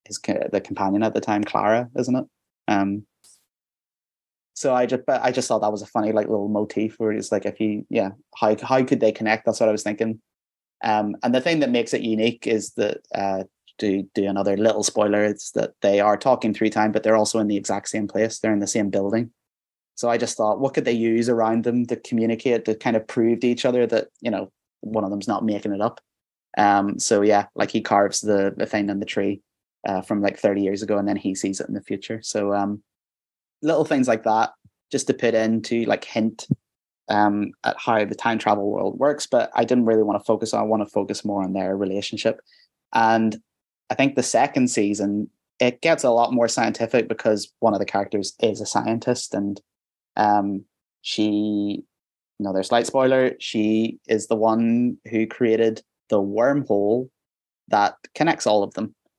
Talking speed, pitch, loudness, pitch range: 210 wpm, 110 Hz, -22 LUFS, 100-115 Hz